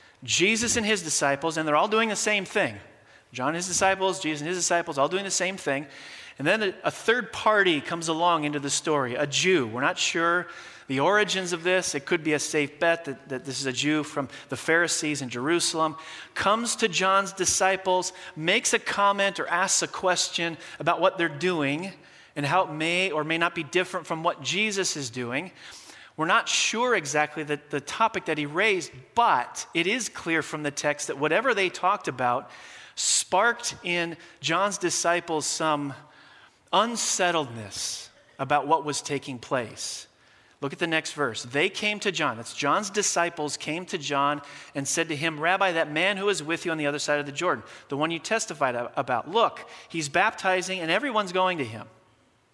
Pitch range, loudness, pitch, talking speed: 150-190 Hz, -25 LUFS, 170 Hz, 195 wpm